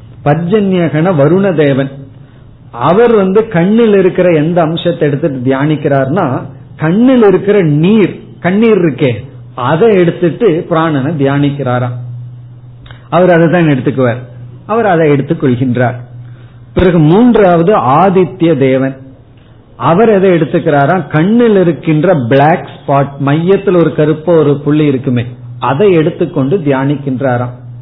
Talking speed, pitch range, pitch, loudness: 100 wpm, 130-175 Hz, 150 Hz, -10 LUFS